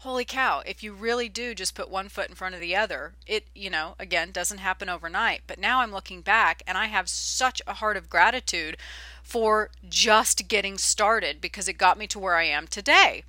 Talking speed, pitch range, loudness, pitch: 215 wpm, 185-230 Hz, -24 LUFS, 200 Hz